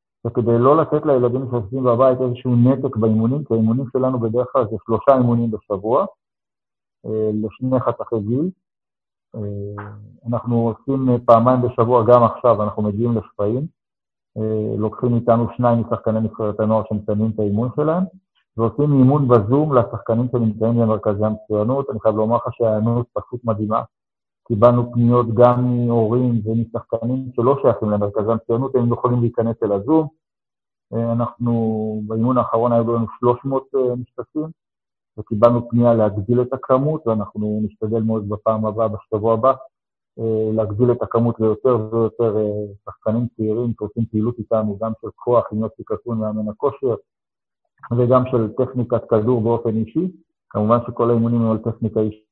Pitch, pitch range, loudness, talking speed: 115 Hz, 110-125 Hz, -19 LUFS, 135 wpm